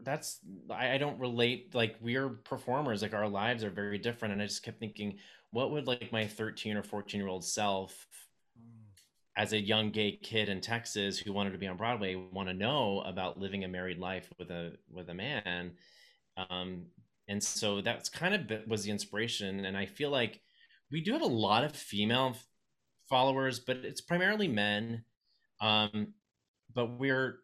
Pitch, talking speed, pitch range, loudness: 105 Hz, 185 wpm, 100-120 Hz, -34 LUFS